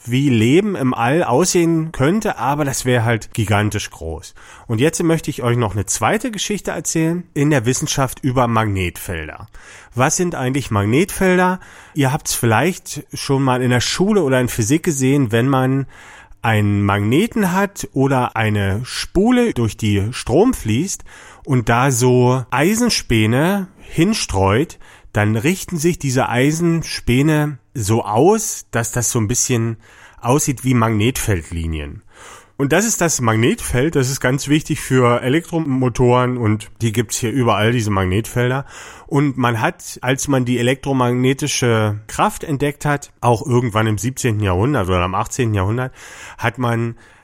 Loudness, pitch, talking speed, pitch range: -17 LUFS, 125 Hz, 150 wpm, 115-150 Hz